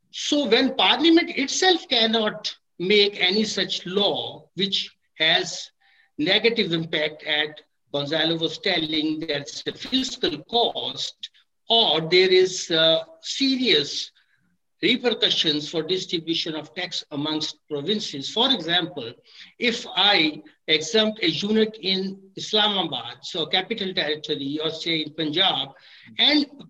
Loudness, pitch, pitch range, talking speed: -22 LUFS, 185 Hz, 155-220 Hz, 110 wpm